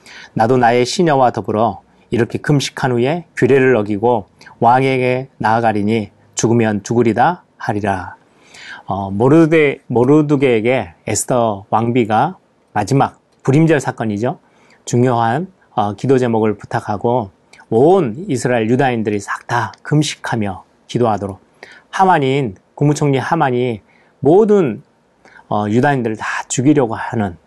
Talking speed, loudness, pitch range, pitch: 280 characters per minute, -15 LUFS, 110-135 Hz, 120 Hz